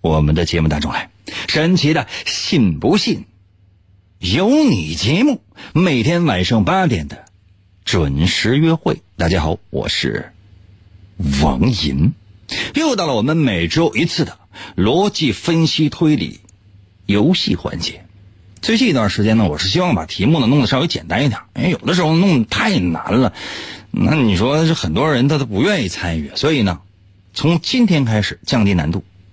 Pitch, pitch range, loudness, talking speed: 100 Hz, 95-155 Hz, -16 LUFS, 235 characters per minute